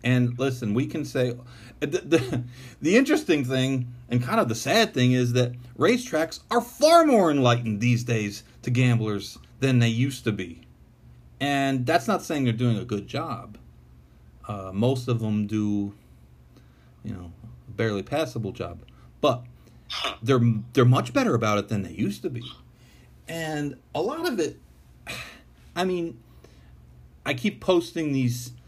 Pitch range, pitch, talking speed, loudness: 105-135 Hz, 120 Hz, 155 wpm, -25 LUFS